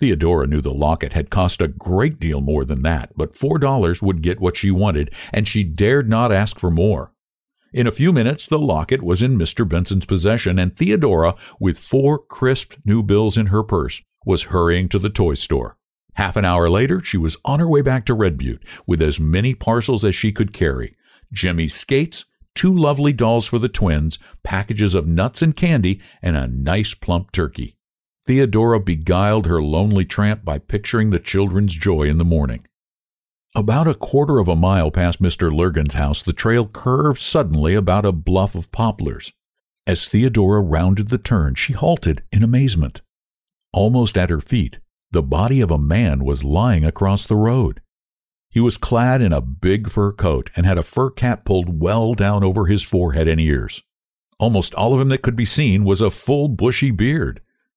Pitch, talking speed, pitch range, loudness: 100 Hz, 190 wpm, 85-115 Hz, -18 LUFS